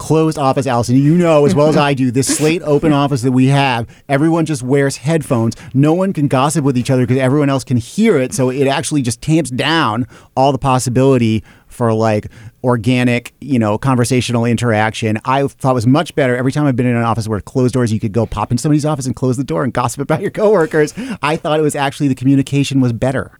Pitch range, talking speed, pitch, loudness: 125-145 Hz, 235 wpm, 135 Hz, -14 LUFS